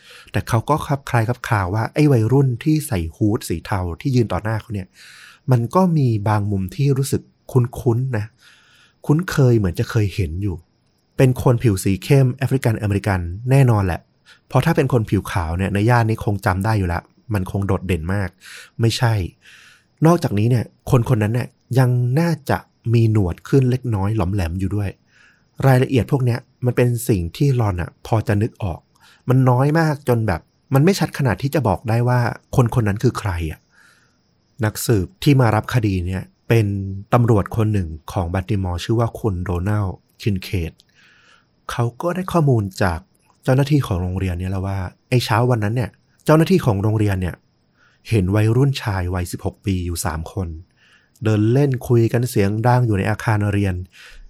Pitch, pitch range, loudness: 110 Hz, 100-125 Hz, -19 LUFS